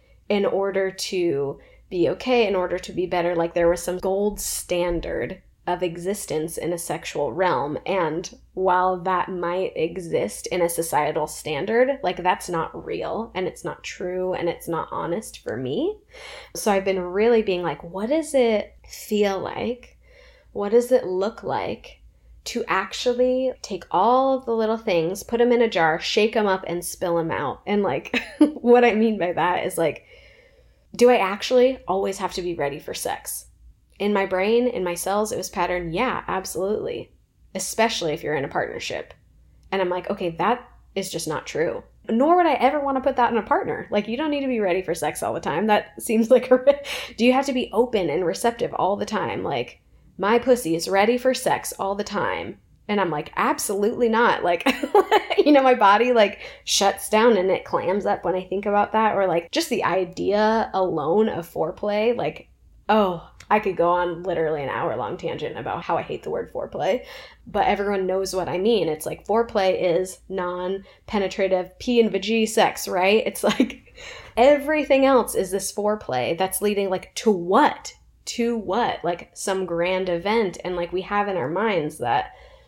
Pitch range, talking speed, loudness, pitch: 180-245 Hz, 195 wpm, -22 LUFS, 205 Hz